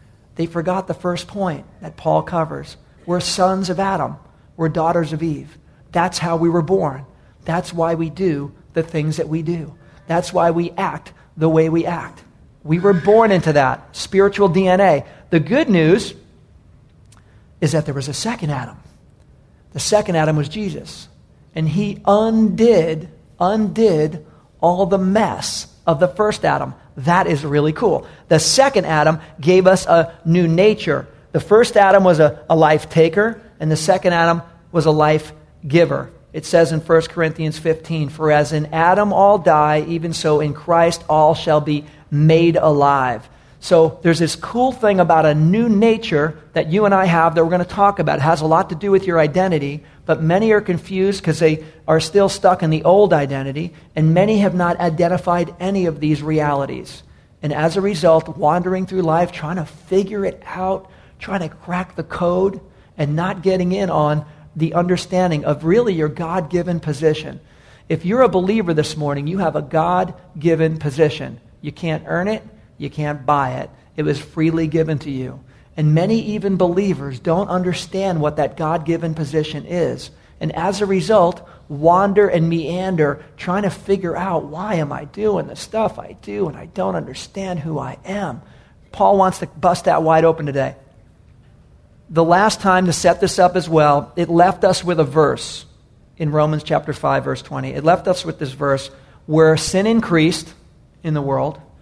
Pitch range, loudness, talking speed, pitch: 155-185 Hz, -17 LUFS, 180 wpm, 165 Hz